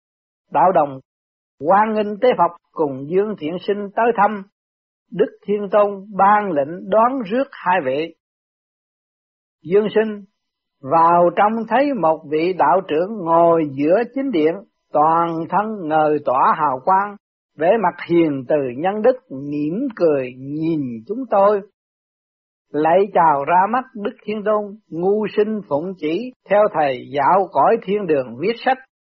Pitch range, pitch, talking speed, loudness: 155-210 Hz, 190 Hz, 145 wpm, -18 LUFS